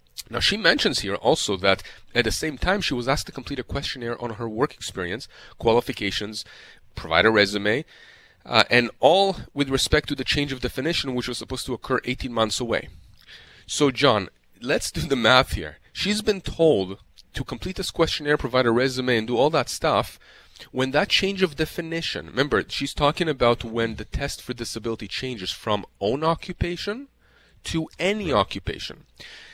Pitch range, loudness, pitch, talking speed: 110-155 Hz, -23 LUFS, 130 Hz, 175 wpm